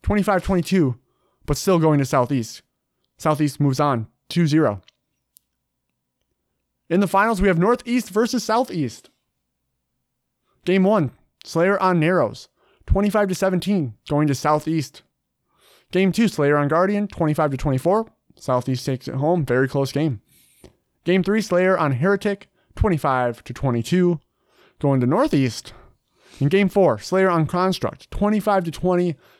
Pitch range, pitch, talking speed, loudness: 135-190 Hz, 160 Hz, 115 wpm, -20 LUFS